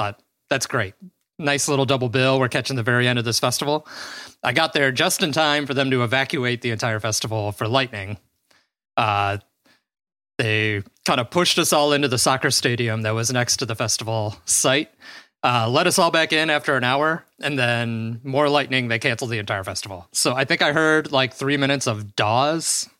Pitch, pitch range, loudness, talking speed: 130 Hz, 115-145 Hz, -20 LUFS, 200 wpm